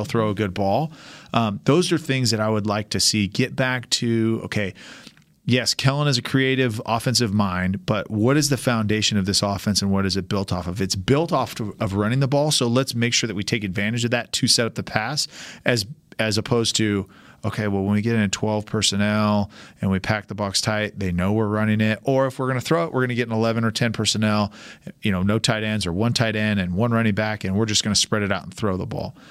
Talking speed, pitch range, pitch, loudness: 260 wpm, 105-120 Hz, 110 Hz, -22 LUFS